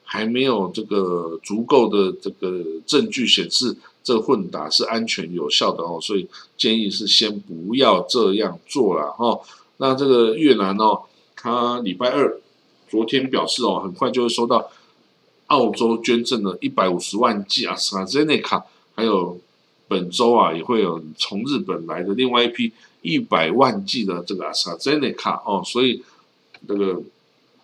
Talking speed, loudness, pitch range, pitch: 245 characters per minute, -20 LUFS, 95-125 Hz, 115 Hz